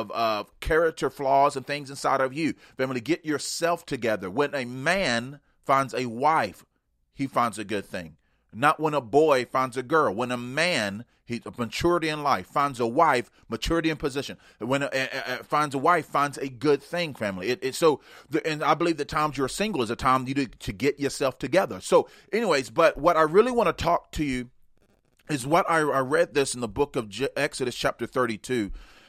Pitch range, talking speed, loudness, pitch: 125-155 Hz, 210 wpm, -25 LUFS, 140 Hz